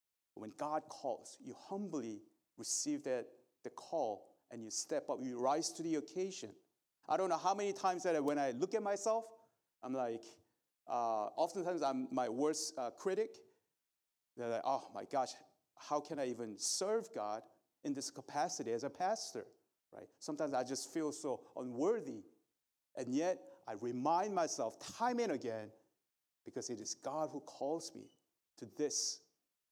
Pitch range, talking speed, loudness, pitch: 125-200 Hz, 160 wpm, -40 LUFS, 155 Hz